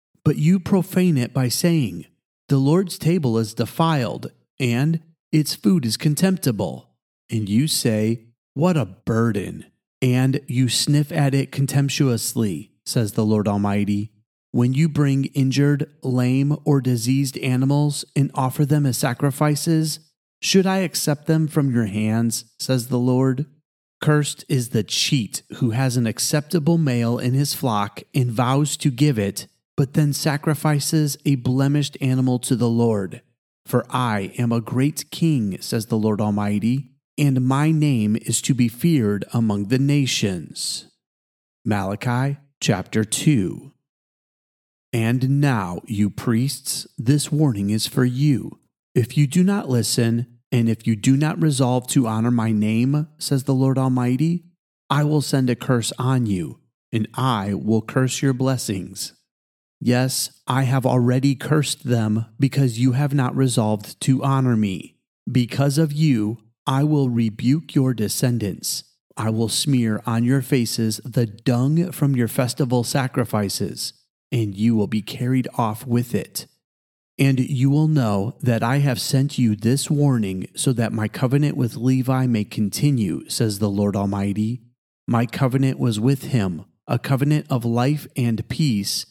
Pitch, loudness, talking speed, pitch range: 130 Hz, -21 LUFS, 150 wpm, 115-145 Hz